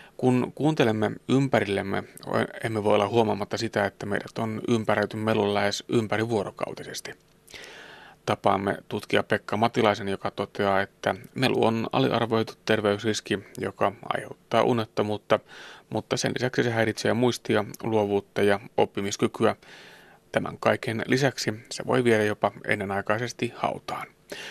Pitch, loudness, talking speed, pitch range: 110 Hz, -26 LUFS, 115 wpm, 100-115 Hz